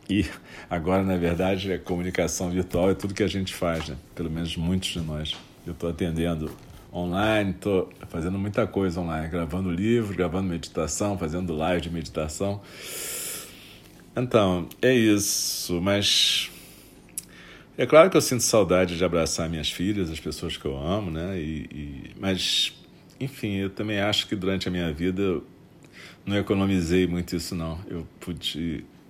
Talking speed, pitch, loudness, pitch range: 155 wpm, 90 Hz, -25 LUFS, 85-100 Hz